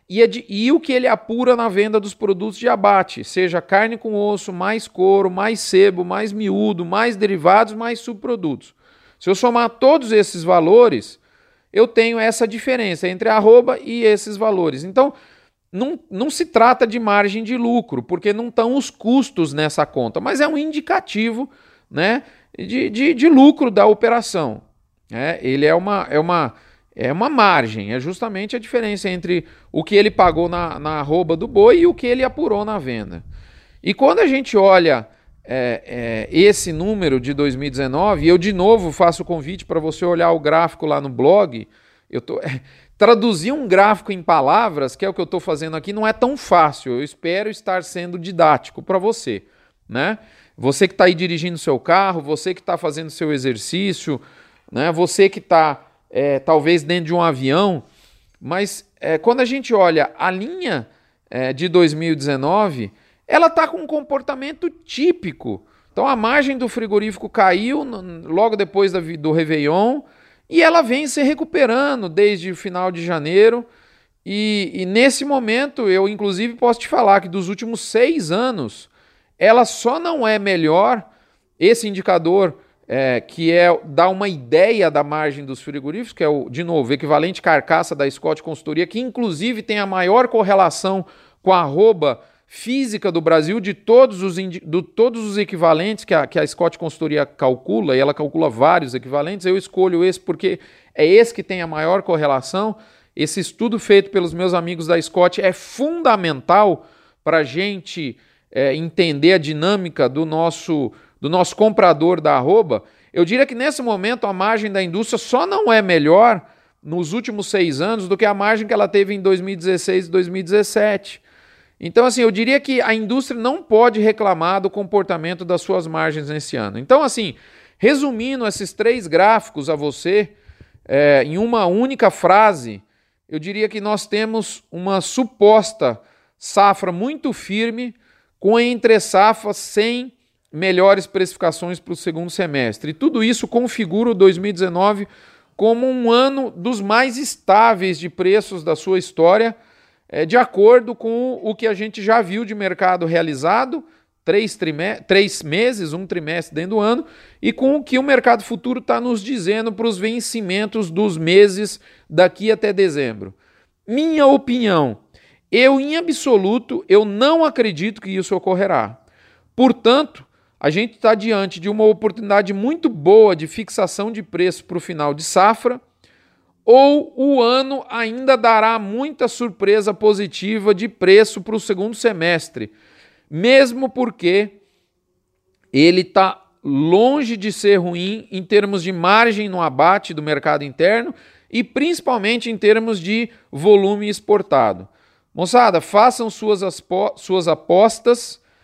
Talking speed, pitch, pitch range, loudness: 160 wpm, 200 Hz, 170-235 Hz, -17 LUFS